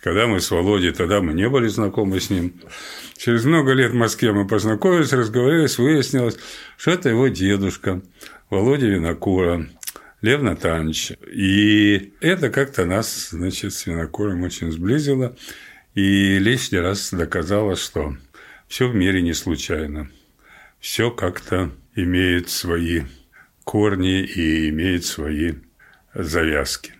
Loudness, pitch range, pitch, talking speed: -20 LUFS, 90-115 Hz, 95 Hz, 125 wpm